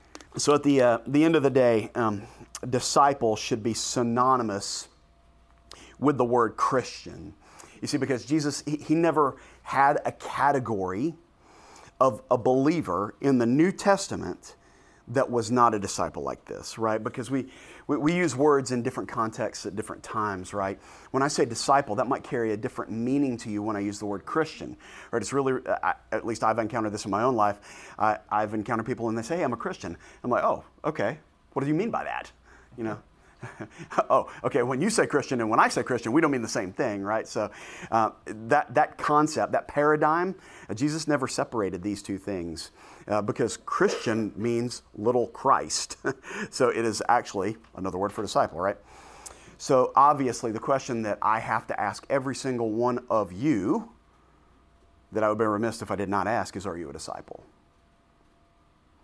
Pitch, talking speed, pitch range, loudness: 115 Hz, 185 wpm, 105-135 Hz, -26 LUFS